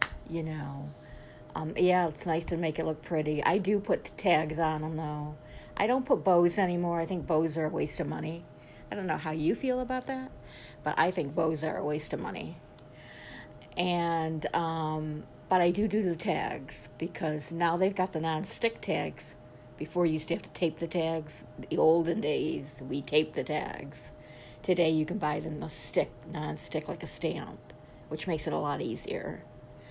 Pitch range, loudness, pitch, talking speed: 155-175 Hz, -31 LUFS, 160 Hz, 195 wpm